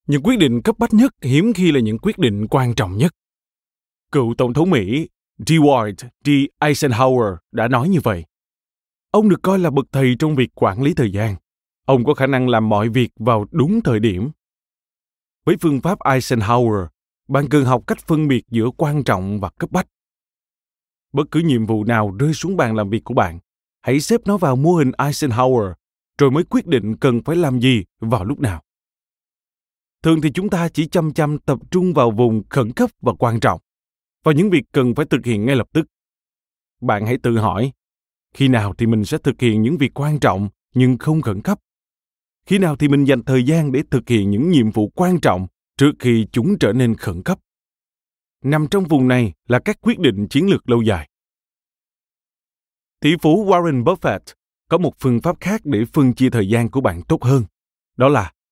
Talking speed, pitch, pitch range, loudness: 200 wpm, 135 Hz, 115-155 Hz, -17 LUFS